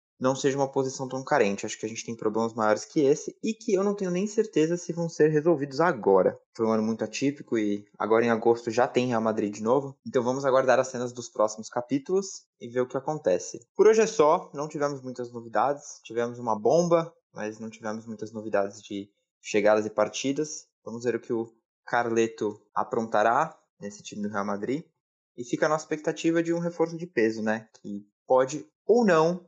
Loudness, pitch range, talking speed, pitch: -27 LUFS, 110-160 Hz, 205 wpm, 125 Hz